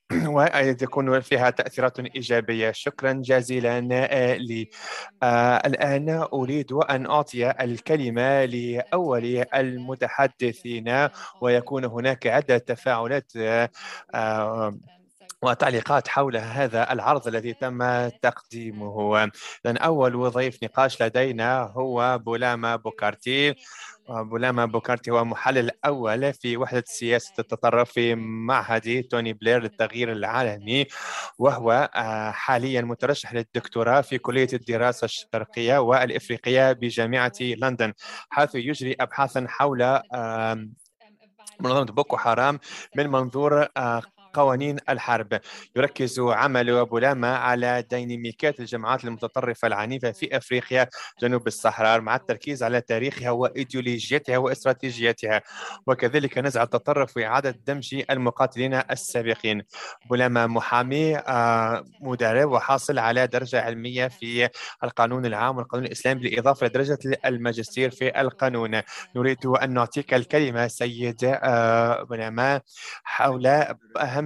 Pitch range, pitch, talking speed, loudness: 115-135 Hz, 125 Hz, 100 wpm, -24 LUFS